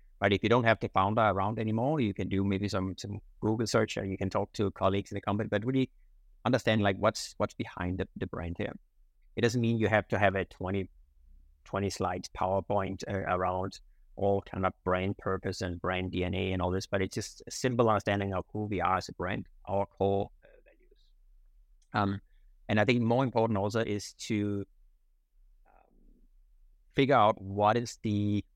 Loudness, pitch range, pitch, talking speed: -31 LUFS, 95-110 Hz, 100 Hz, 195 wpm